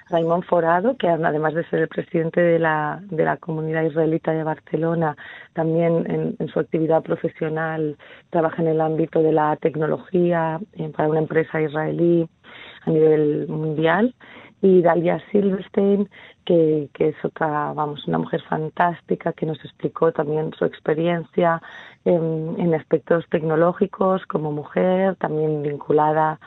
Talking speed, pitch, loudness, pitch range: 140 wpm, 160 Hz, -21 LUFS, 155-170 Hz